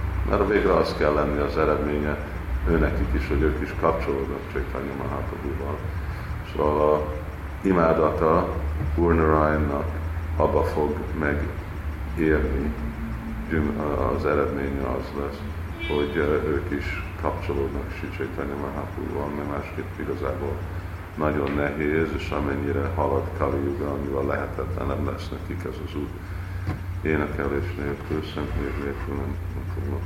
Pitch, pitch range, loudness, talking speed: 80 Hz, 75-90 Hz, -26 LUFS, 115 wpm